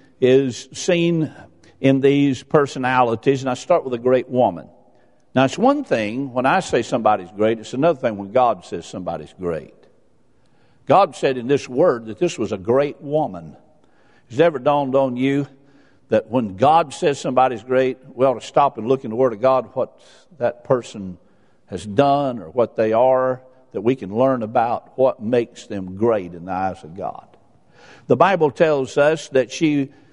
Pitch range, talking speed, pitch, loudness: 120-140 Hz, 180 wpm, 130 Hz, -19 LUFS